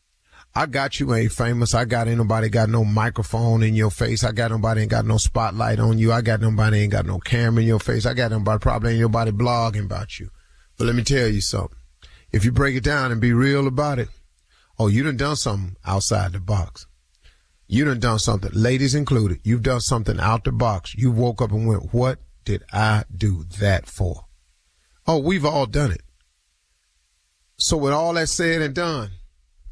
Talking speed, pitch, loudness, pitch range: 205 wpm, 110 Hz, -21 LUFS, 100-120 Hz